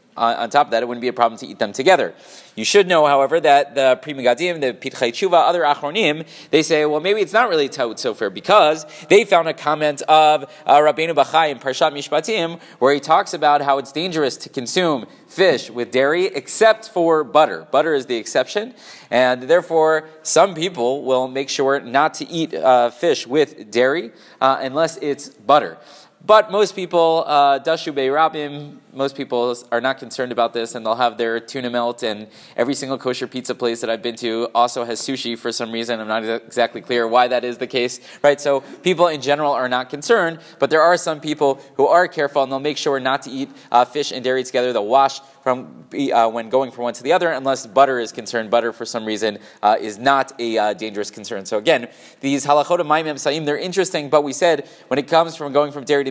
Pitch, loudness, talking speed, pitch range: 140 Hz, -18 LUFS, 215 wpm, 125-155 Hz